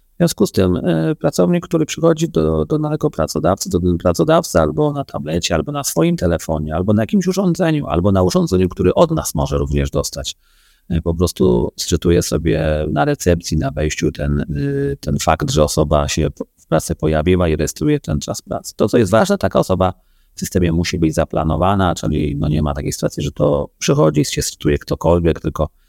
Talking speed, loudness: 195 wpm, -17 LUFS